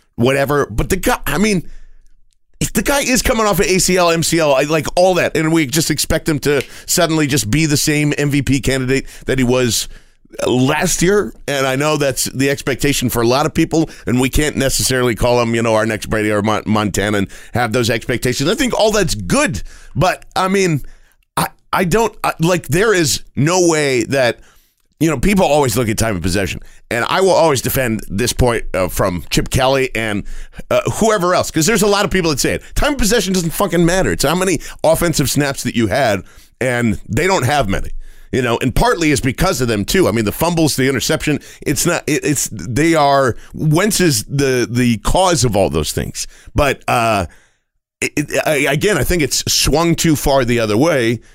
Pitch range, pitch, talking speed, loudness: 120-165 Hz, 140 Hz, 210 wpm, -15 LUFS